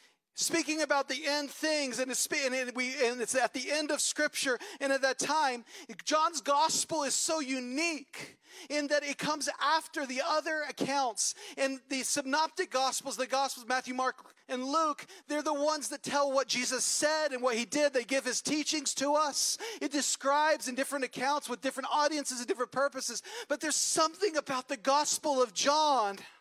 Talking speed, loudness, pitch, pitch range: 175 wpm, -31 LUFS, 285 Hz, 260-305 Hz